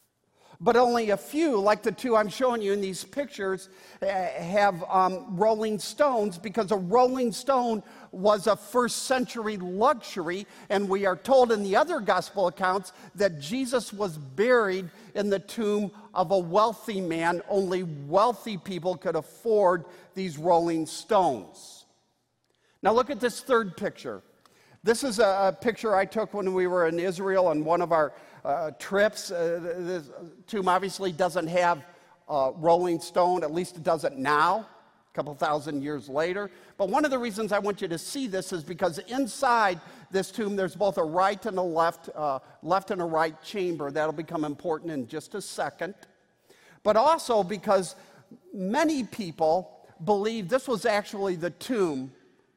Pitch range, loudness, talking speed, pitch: 175-220 Hz, -27 LUFS, 165 wpm, 195 Hz